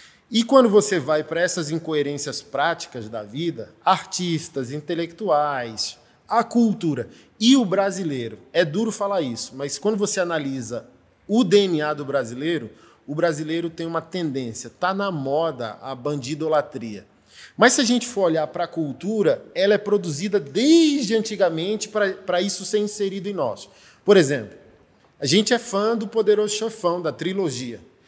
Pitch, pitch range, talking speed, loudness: 170 Hz, 145-205 Hz, 150 wpm, -21 LUFS